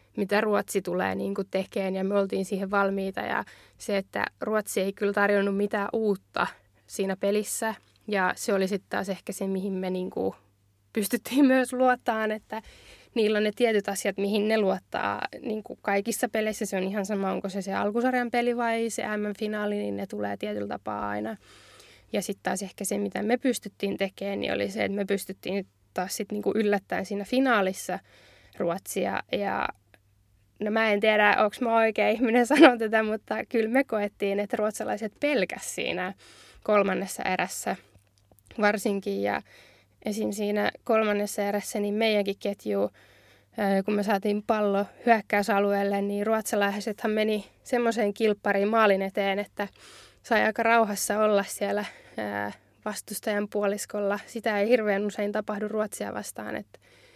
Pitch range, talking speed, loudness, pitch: 195-215 Hz, 155 wpm, -27 LUFS, 205 Hz